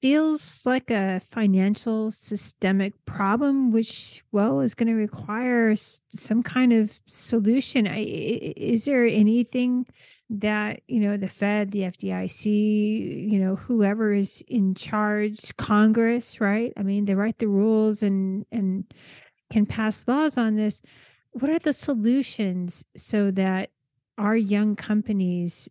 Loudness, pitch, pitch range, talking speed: -24 LUFS, 215 Hz, 200-230 Hz, 135 wpm